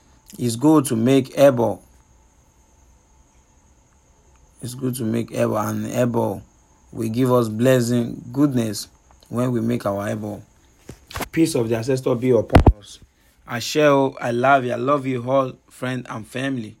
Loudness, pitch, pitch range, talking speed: -20 LUFS, 115 Hz, 85-130 Hz, 135 wpm